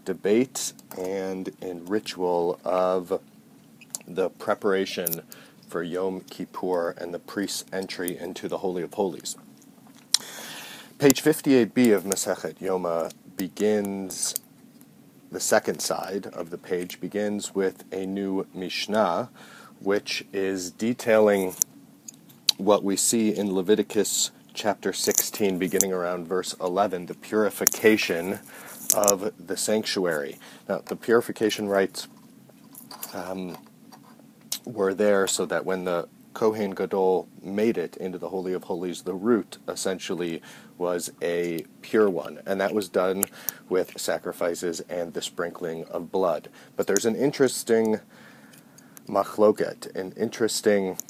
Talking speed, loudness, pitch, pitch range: 115 wpm, -26 LUFS, 95 Hz, 90-105 Hz